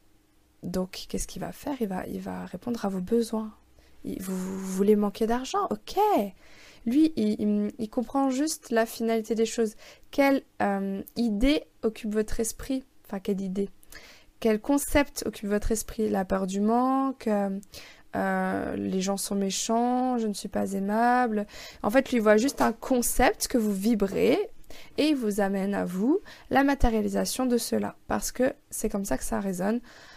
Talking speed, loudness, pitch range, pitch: 175 wpm, -27 LUFS, 200-250 Hz, 220 Hz